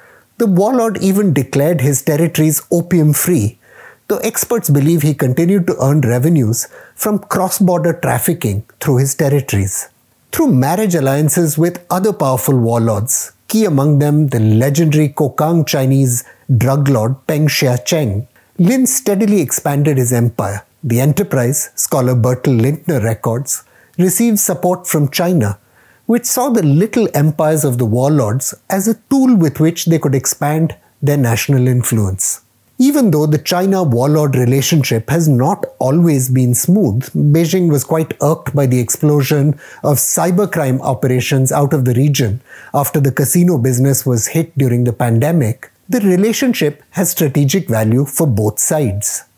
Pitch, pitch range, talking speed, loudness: 145 Hz, 130-170 Hz, 140 wpm, -14 LUFS